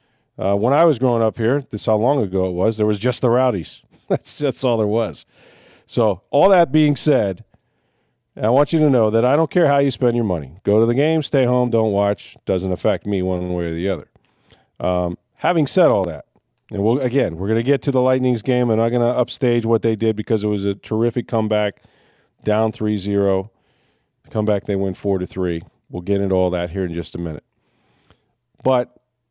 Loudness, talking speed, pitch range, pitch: -19 LUFS, 225 wpm, 100-125 Hz, 110 Hz